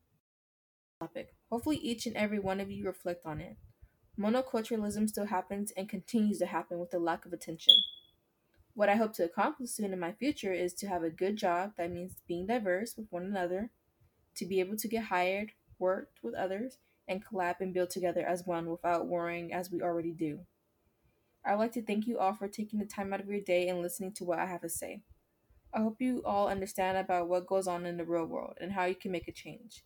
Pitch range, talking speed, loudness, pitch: 175-210 Hz, 220 wpm, -34 LUFS, 185 Hz